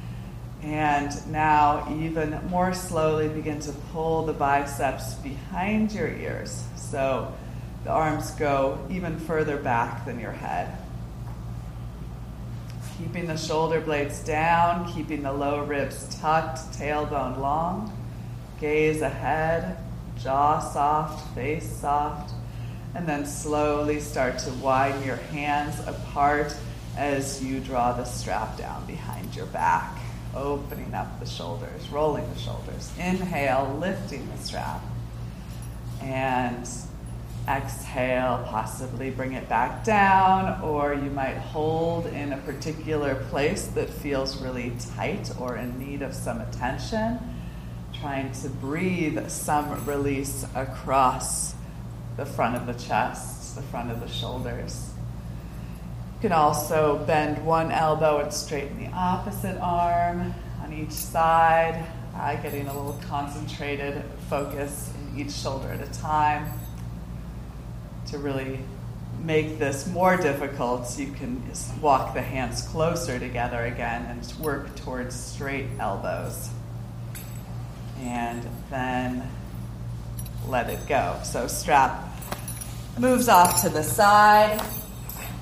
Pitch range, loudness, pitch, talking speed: 120-155 Hz, -27 LUFS, 140 Hz, 120 wpm